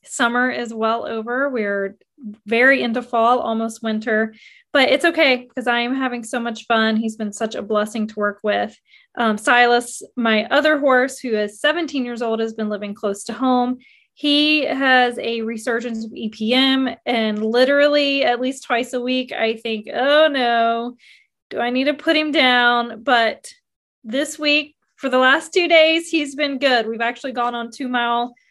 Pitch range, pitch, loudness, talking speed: 225-275 Hz, 245 Hz, -18 LUFS, 180 wpm